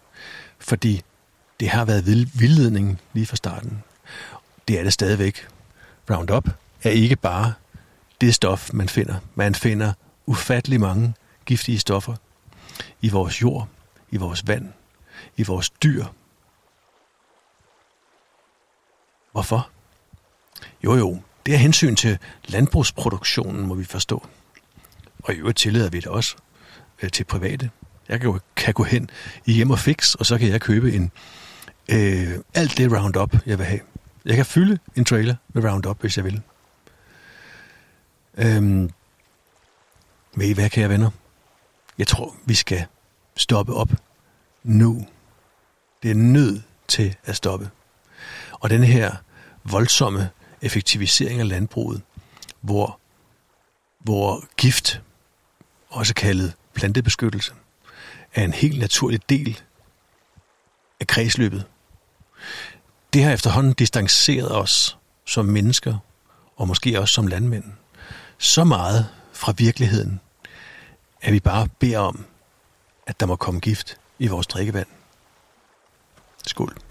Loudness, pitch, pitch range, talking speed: -20 LUFS, 110 Hz, 100-120 Hz, 120 wpm